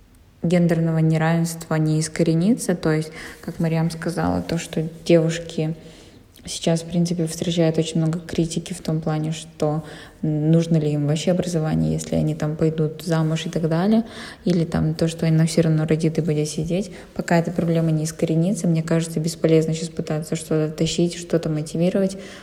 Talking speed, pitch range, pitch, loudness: 165 wpm, 155-170 Hz, 165 Hz, -22 LUFS